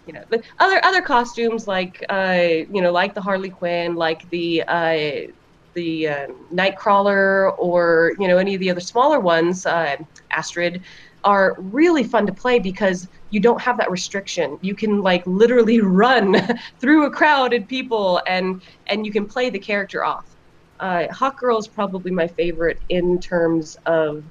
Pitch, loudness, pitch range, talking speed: 190 Hz, -19 LUFS, 175-225 Hz, 170 wpm